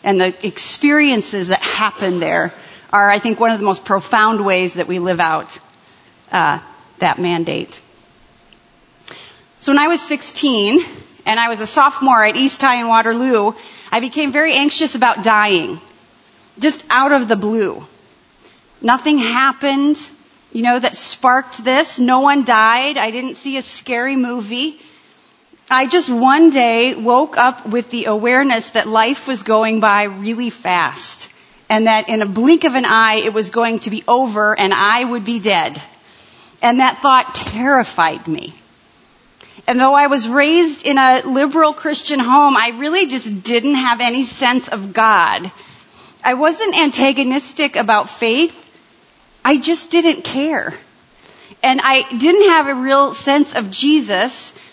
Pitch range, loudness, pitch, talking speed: 220-285 Hz, -14 LUFS, 250 Hz, 155 wpm